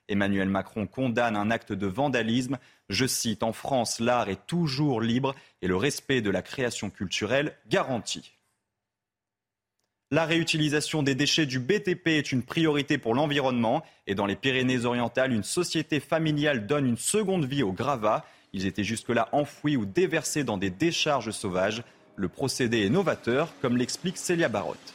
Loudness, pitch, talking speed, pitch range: -27 LUFS, 125 Hz, 160 wpm, 105-150 Hz